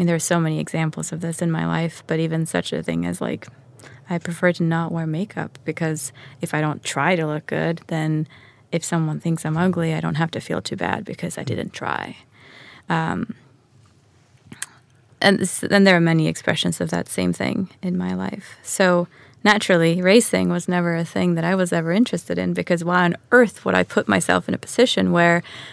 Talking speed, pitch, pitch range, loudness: 210 wpm, 160 Hz, 130-175 Hz, -21 LUFS